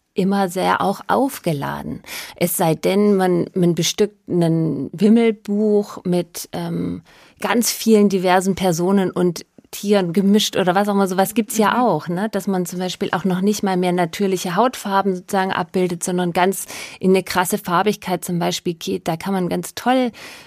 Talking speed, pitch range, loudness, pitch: 170 wpm, 180-205 Hz, -19 LUFS, 190 Hz